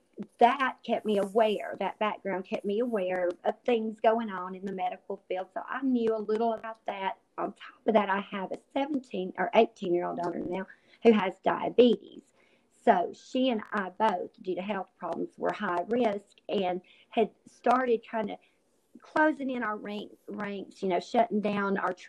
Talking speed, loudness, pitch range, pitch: 185 wpm, -30 LUFS, 185-230 Hz, 210 Hz